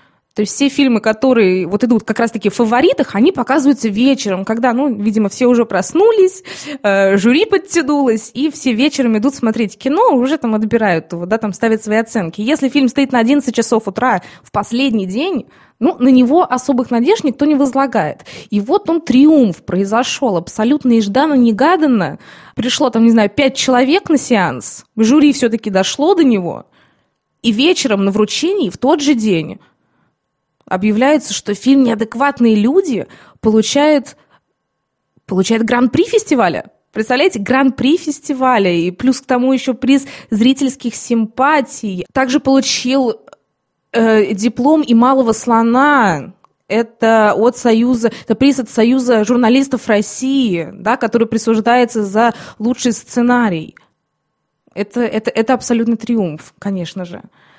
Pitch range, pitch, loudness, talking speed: 220-270 Hz, 240 Hz, -13 LUFS, 140 wpm